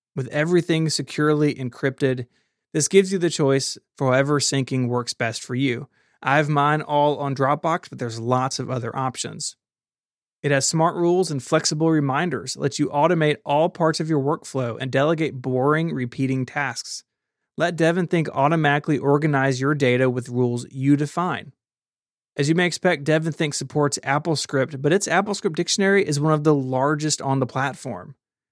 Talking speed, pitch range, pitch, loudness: 160 wpm, 130-160 Hz, 145 Hz, -22 LUFS